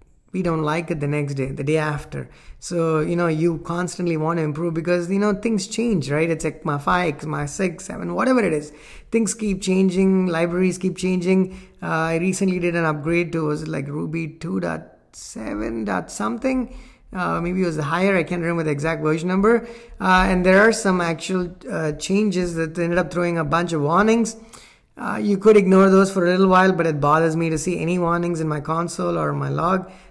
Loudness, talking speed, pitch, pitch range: -21 LUFS, 210 wpm, 175 Hz, 160-190 Hz